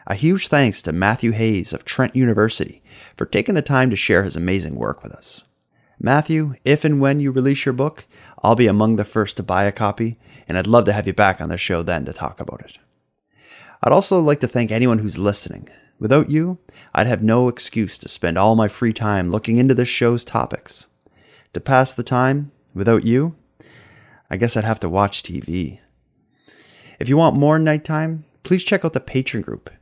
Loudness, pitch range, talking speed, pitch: -18 LUFS, 100-140 Hz, 205 wpm, 120 Hz